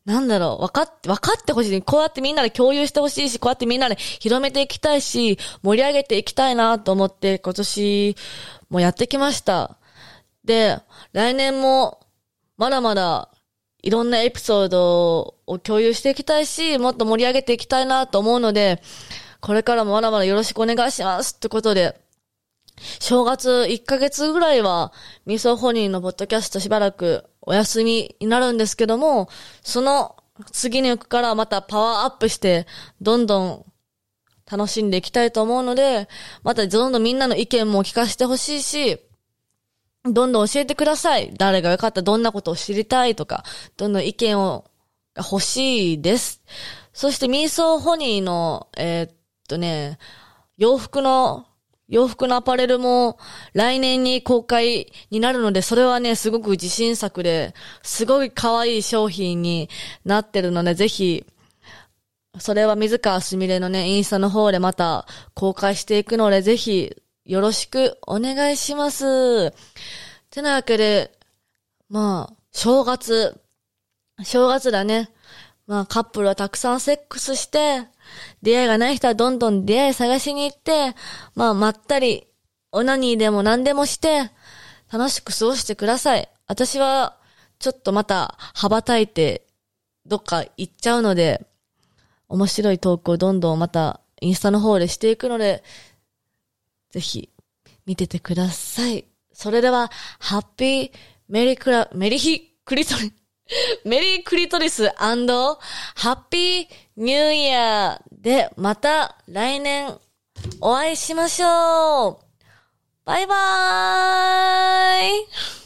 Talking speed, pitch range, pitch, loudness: 300 characters per minute, 195-260 Hz, 225 Hz, -20 LUFS